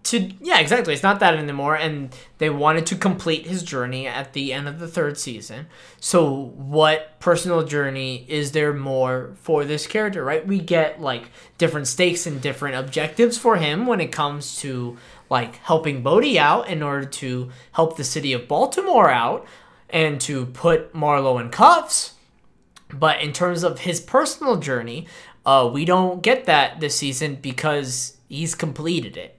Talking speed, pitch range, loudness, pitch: 170 wpm, 135-170 Hz, -20 LUFS, 155 Hz